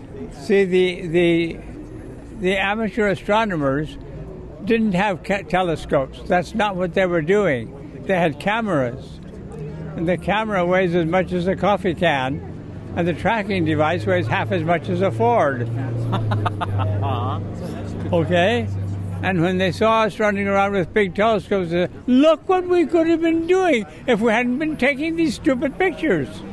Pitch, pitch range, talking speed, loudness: 185 Hz, 155-220 Hz, 155 wpm, -20 LUFS